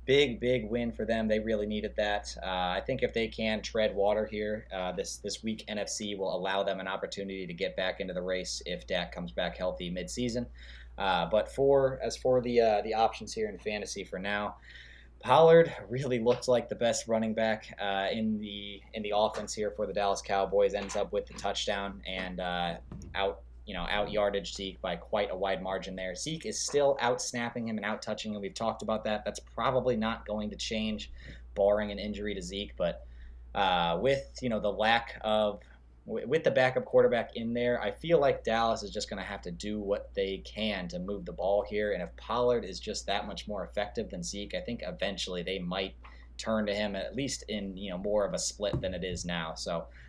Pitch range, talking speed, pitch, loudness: 95-115 Hz, 220 wpm, 105 Hz, -31 LUFS